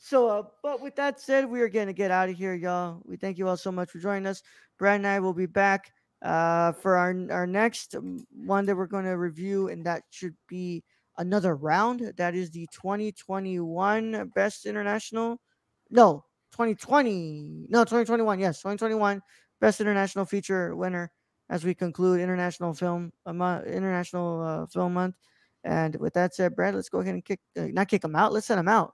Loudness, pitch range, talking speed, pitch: -27 LUFS, 180-210 Hz, 190 wpm, 190 Hz